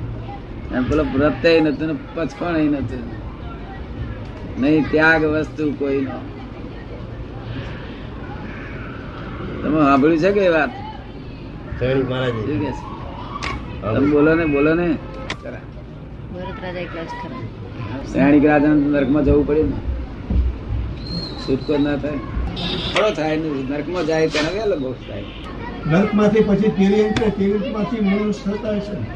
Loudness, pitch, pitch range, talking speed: -19 LUFS, 145 Hz, 125-160 Hz, 80 wpm